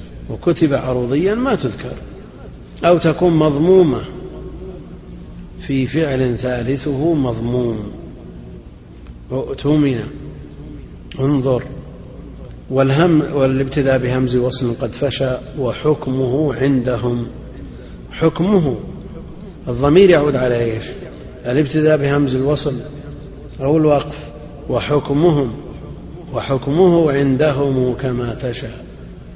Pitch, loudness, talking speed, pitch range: 135 Hz, -17 LUFS, 75 wpm, 125-150 Hz